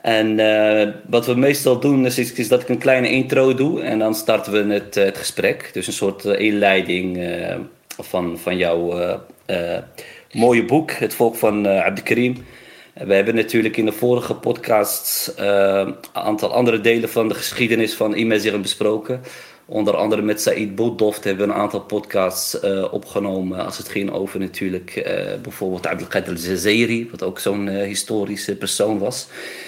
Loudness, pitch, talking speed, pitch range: -19 LUFS, 105 Hz, 170 wpm, 100-120 Hz